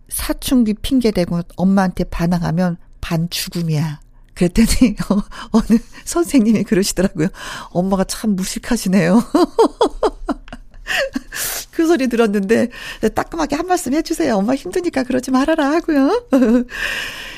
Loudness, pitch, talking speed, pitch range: -17 LUFS, 230 Hz, 275 characters per minute, 185-275 Hz